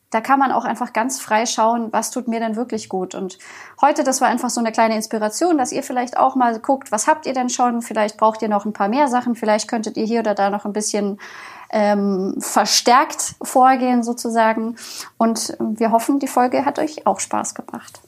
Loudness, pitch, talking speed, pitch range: -19 LUFS, 230 Hz, 215 wpm, 215-250 Hz